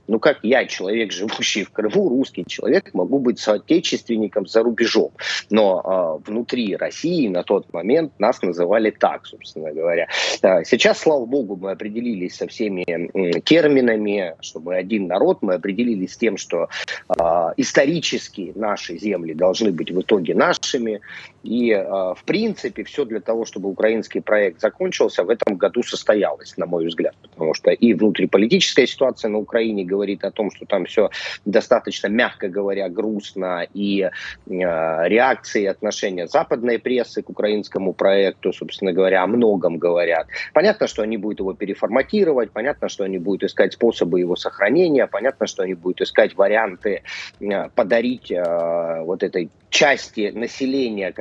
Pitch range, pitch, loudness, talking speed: 95-115 Hz, 105 Hz, -20 LUFS, 150 wpm